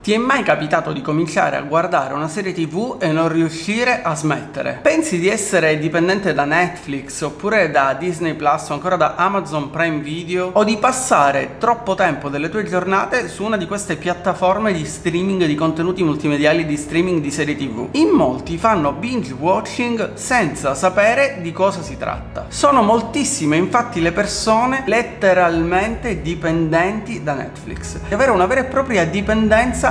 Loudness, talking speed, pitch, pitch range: -17 LUFS, 165 wpm, 180 Hz, 160-220 Hz